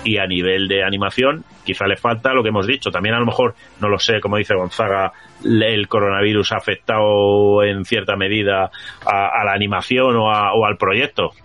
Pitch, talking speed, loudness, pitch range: 100 Hz, 200 wpm, -17 LUFS, 95-110 Hz